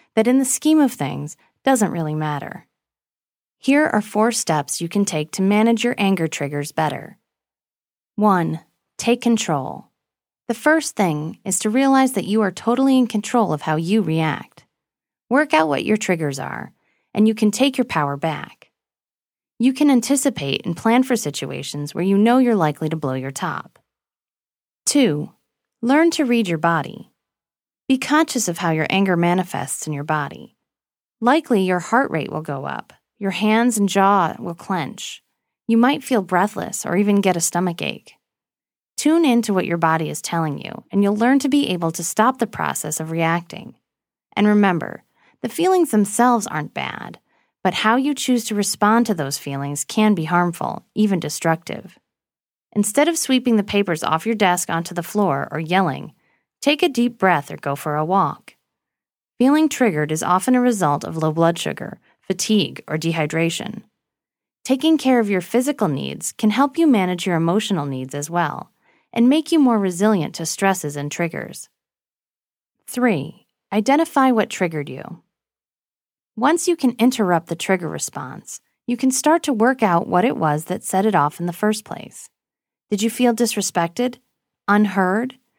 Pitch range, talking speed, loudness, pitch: 165-245 Hz, 170 wpm, -19 LUFS, 205 Hz